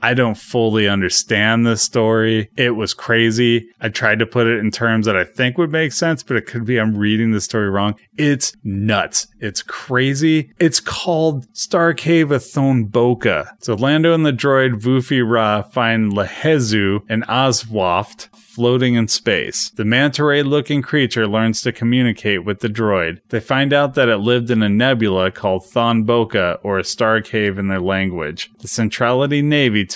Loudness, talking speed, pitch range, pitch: -17 LUFS, 175 wpm, 110-135 Hz, 115 Hz